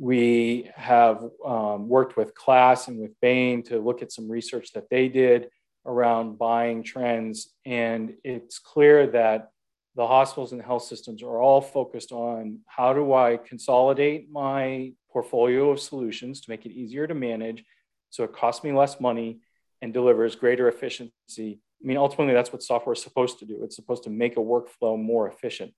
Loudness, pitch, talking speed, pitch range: -23 LUFS, 120 Hz, 175 wpm, 115-130 Hz